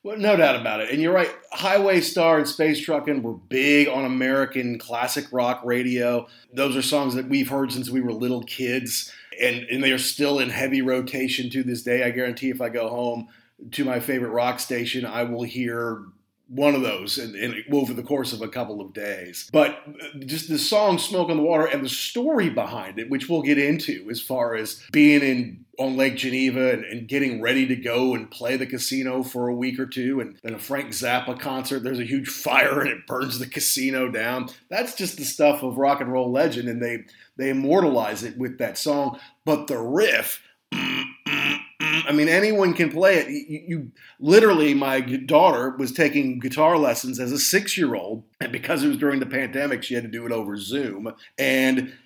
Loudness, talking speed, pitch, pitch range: -22 LUFS, 205 wpm, 130 Hz, 125-145 Hz